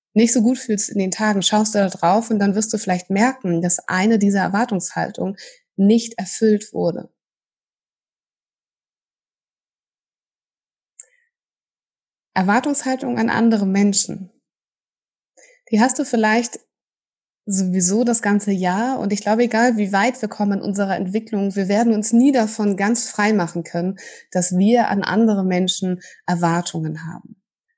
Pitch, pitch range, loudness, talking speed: 210 Hz, 190-230 Hz, -19 LUFS, 135 wpm